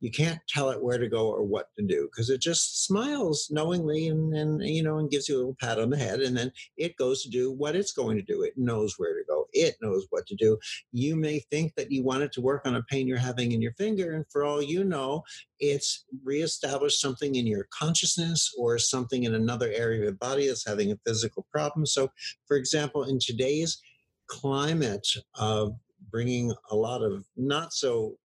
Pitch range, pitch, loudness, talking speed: 125-155 Hz, 140 Hz, -28 LUFS, 220 wpm